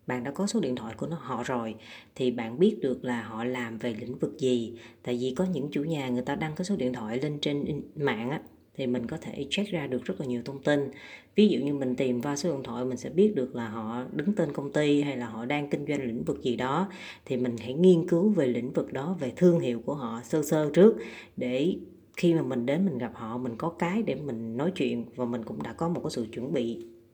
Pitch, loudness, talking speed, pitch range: 130 Hz, -29 LUFS, 270 wpm, 120-165 Hz